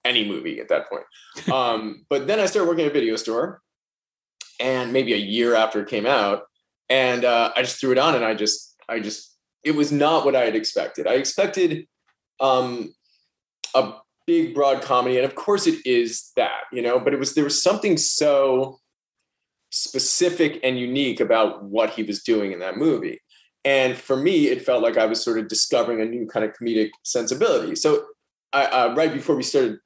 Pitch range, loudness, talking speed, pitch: 115-175 Hz, -21 LUFS, 200 wpm, 135 Hz